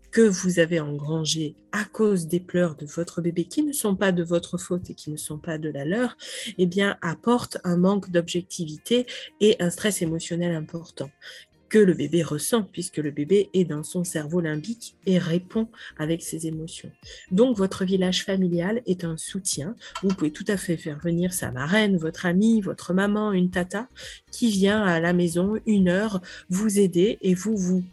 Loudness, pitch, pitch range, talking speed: -24 LUFS, 180 Hz, 165-200 Hz, 185 wpm